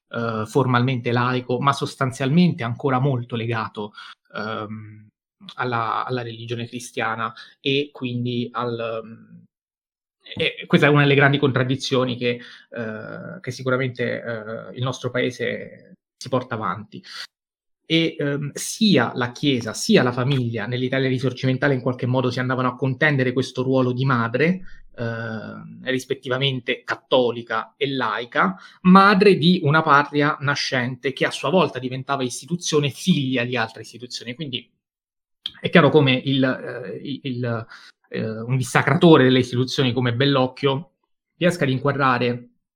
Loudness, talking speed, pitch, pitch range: -21 LUFS, 130 wpm, 130 Hz, 120-140 Hz